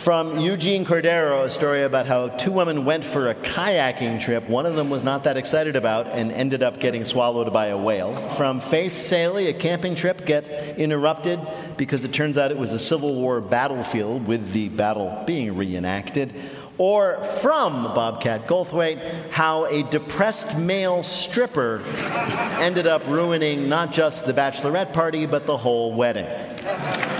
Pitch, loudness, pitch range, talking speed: 150 Hz, -22 LUFS, 125-170 Hz, 165 wpm